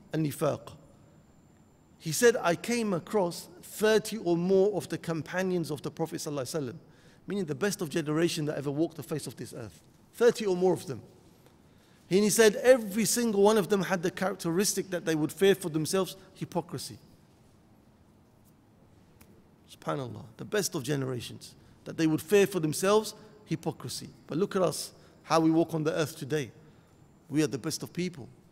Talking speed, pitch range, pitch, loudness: 170 wpm, 155-195 Hz, 170 Hz, -29 LUFS